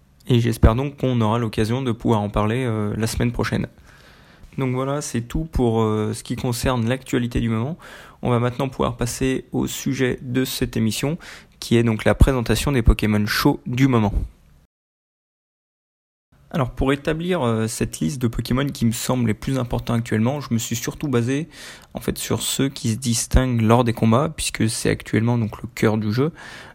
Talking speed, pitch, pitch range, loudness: 190 wpm, 120 Hz, 110-130 Hz, -21 LUFS